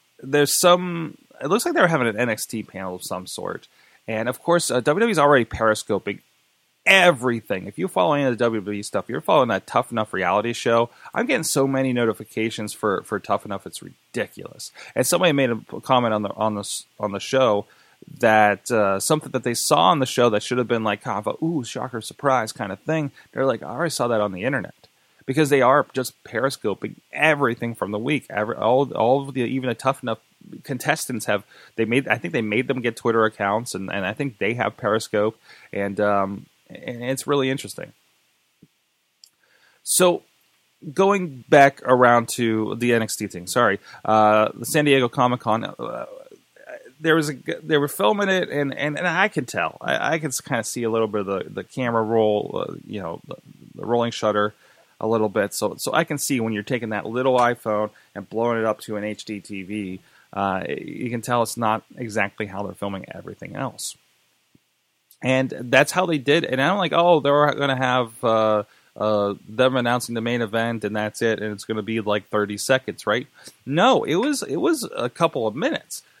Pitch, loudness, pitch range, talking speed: 115 Hz, -22 LUFS, 105-135 Hz, 200 wpm